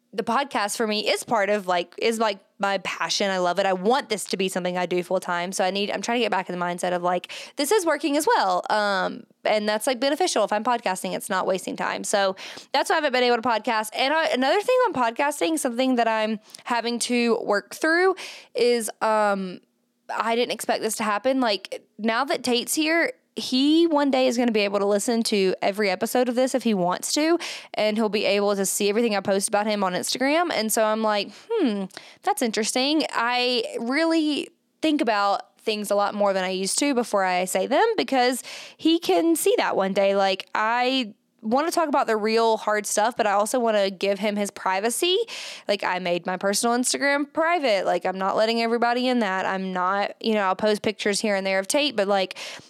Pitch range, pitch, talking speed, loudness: 200-265 Hz, 220 Hz, 225 wpm, -23 LUFS